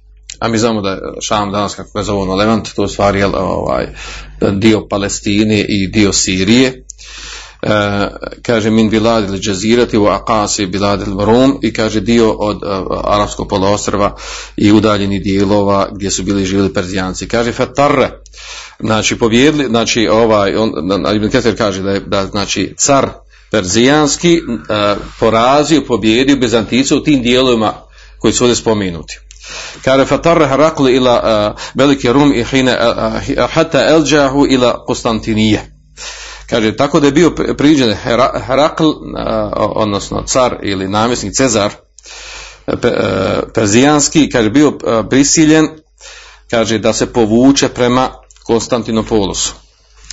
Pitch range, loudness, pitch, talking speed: 100-125 Hz, -12 LUFS, 110 Hz, 125 wpm